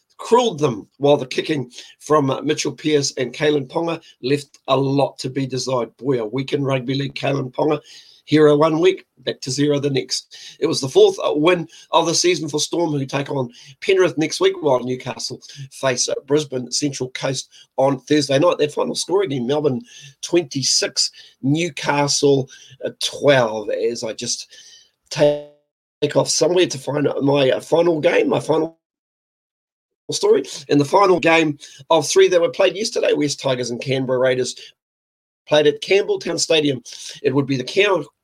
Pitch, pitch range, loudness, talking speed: 145 Hz, 135-165 Hz, -19 LUFS, 170 wpm